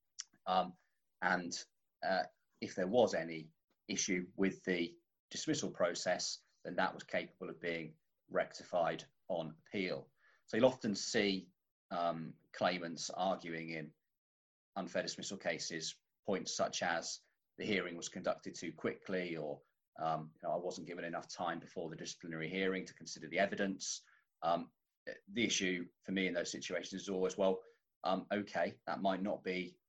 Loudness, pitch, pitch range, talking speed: -39 LUFS, 90 Hz, 80-95 Hz, 150 wpm